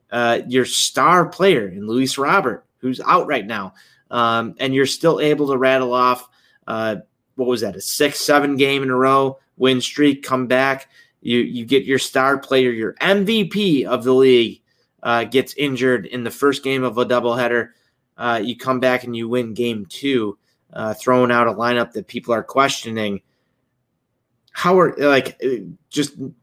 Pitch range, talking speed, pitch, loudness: 120-140 Hz, 175 wpm, 130 Hz, -18 LUFS